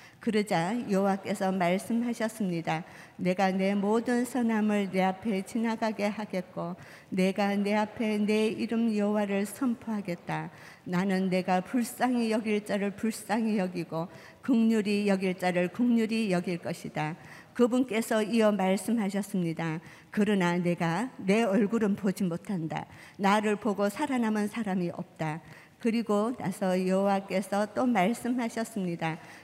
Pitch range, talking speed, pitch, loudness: 185-225 Hz, 280 characters per minute, 200 Hz, -29 LUFS